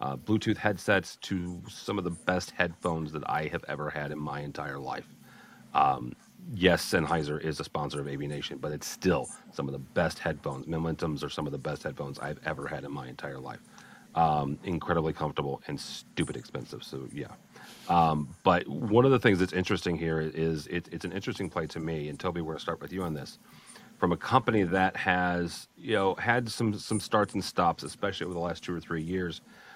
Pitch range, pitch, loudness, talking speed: 75-95 Hz, 85 Hz, -30 LUFS, 210 wpm